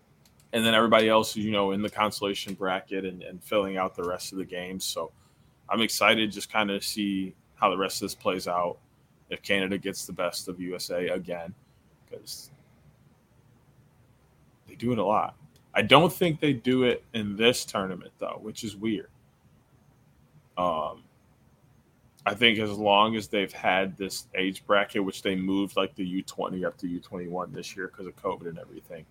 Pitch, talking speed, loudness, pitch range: 100 Hz, 180 wpm, -27 LUFS, 95-110 Hz